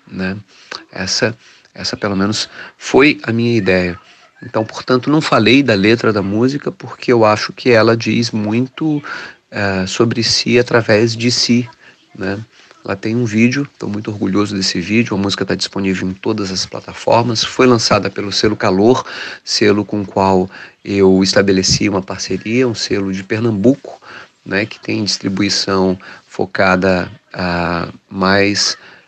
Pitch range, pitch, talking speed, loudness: 95-115 Hz, 105 Hz, 145 wpm, -15 LUFS